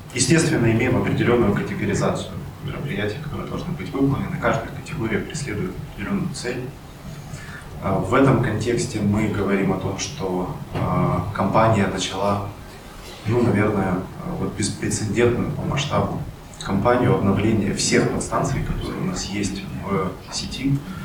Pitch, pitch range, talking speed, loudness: 110 Hz, 100-135 Hz, 110 wpm, -22 LUFS